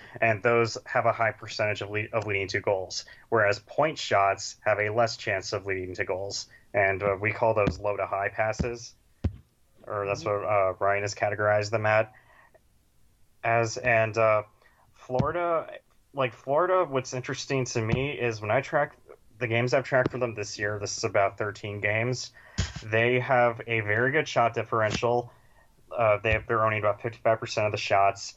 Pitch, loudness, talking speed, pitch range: 115 Hz, -27 LUFS, 180 wpm, 105-125 Hz